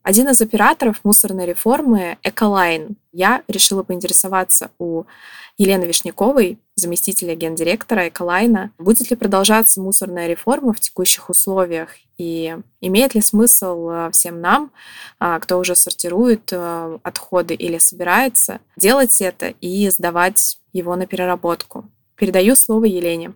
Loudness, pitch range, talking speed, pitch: -15 LUFS, 175-220 Hz, 115 wpm, 190 Hz